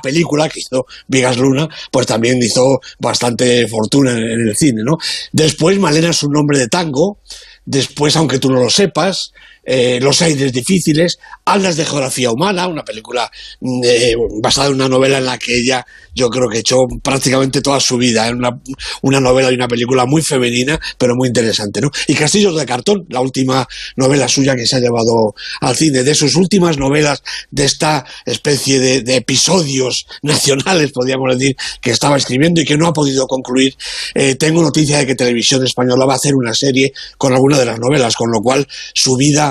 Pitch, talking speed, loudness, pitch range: 135 Hz, 190 wpm, -13 LUFS, 125-150 Hz